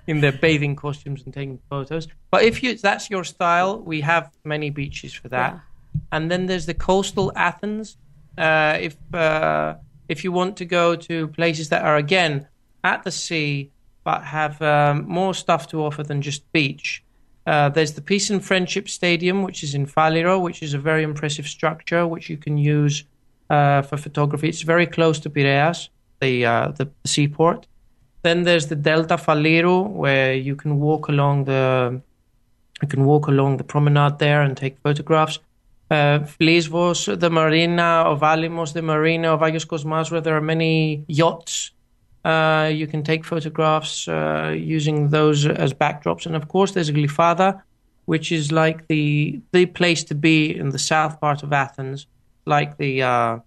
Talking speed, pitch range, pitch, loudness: 170 wpm, 145-170 Hz, 155 Hz, -20 LUFS